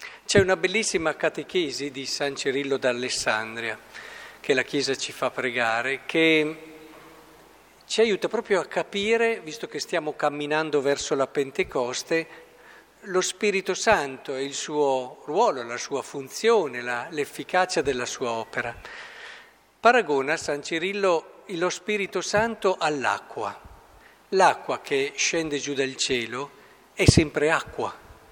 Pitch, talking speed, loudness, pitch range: 155 Hz, 125 wpm, -25 LUFS, 140-200 Hz